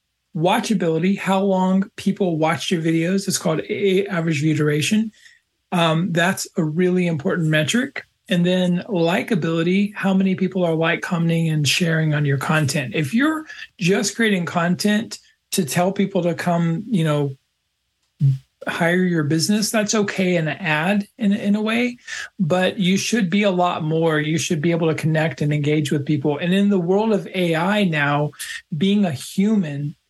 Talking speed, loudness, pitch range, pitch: 165 wpm, -20 LUFS, 160-200 Hz, 180 Hz